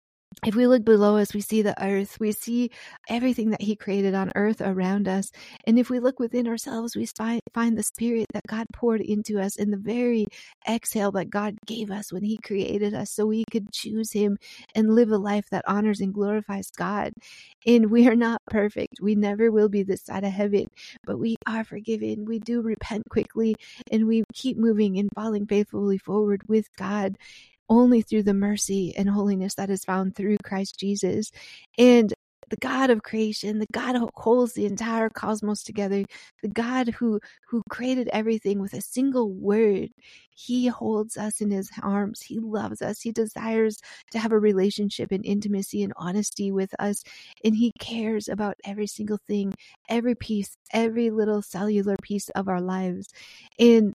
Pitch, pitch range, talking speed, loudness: 215 Hz, 200-225 Hz, 180 wpm, -25 LUFS